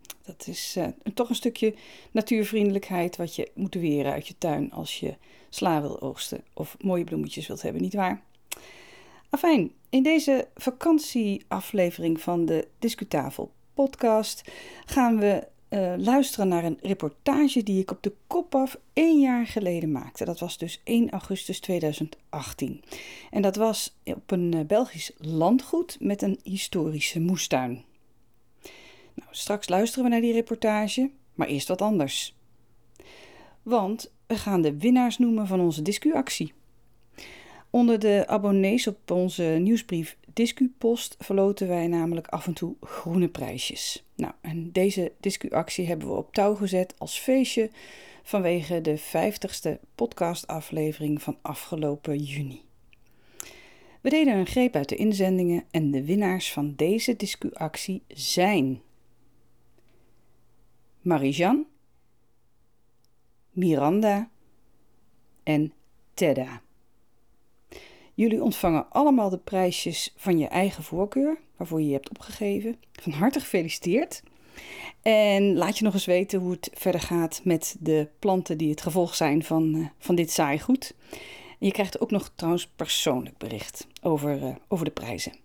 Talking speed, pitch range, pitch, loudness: 135 wpm, 155-225 Hz, 185 Hz, -26 LUFS